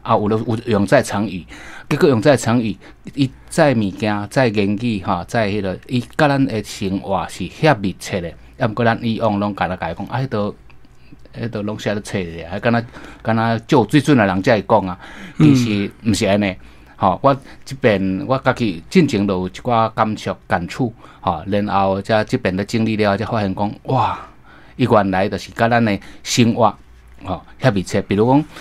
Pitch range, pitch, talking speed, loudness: 100-120 Hz, 110 Hz, 275 characters per minute, -18 LUFS